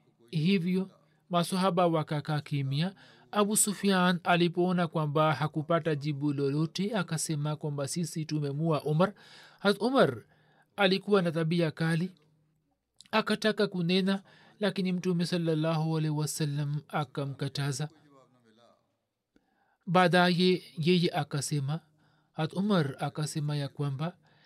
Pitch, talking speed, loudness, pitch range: 160 Hz, 85 wpm, -29 LUFS, 150-185 Hz